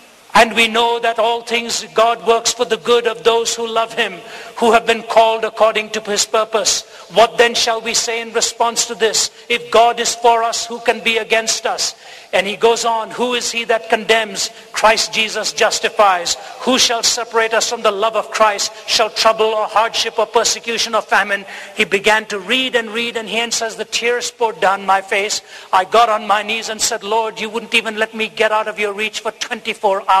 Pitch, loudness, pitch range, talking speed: 225 Hz, -15 LUFS, 215-230 Hz, 215 wpm